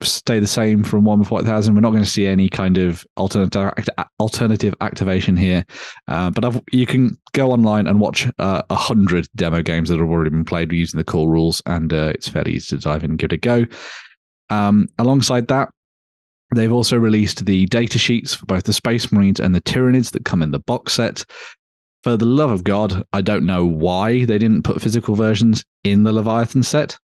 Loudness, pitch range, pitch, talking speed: -17 LUFS, 90-115 Hz, 105 Hz, 210 wpm